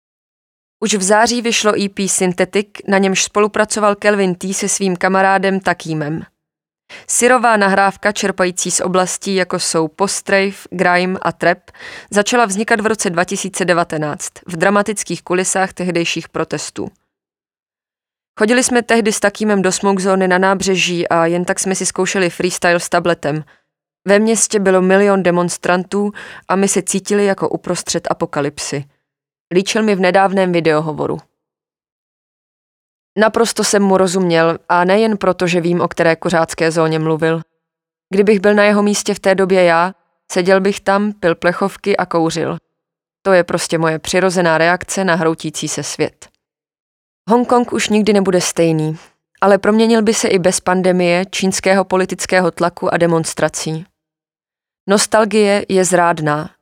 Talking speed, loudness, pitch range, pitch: 140 wpm, -15 LUFS, 170-200 Hz, 185 Hz